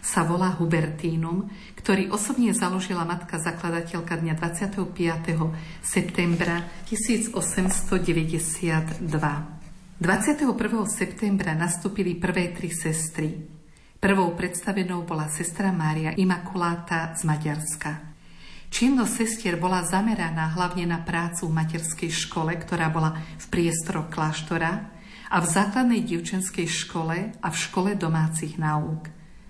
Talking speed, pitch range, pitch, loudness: 105 wpm, 165-190 Hz, 170 Hz, -26 LUFS